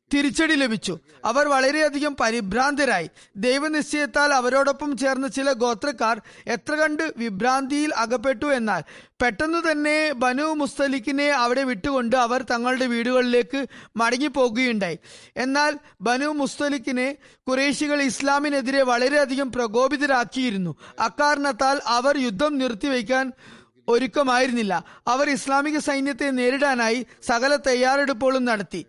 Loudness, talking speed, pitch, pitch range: -22 LUFS, 90 wpm, 265 Hz, 245-285 Hz